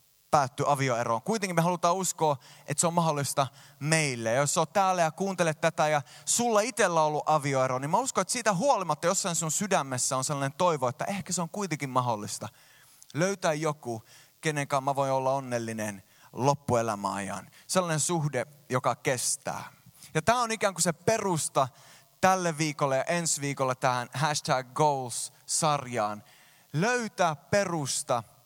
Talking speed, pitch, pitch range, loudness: 150 wpm, 150 Hz, 135-175 Hz, -28 LUFS